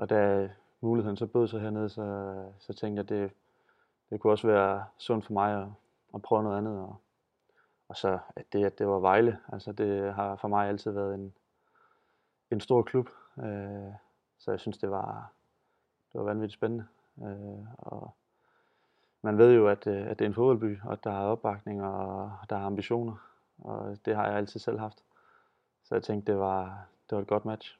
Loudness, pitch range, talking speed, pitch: -30 LUFS, 100-115 Hz, 195 wpm, 105 Hz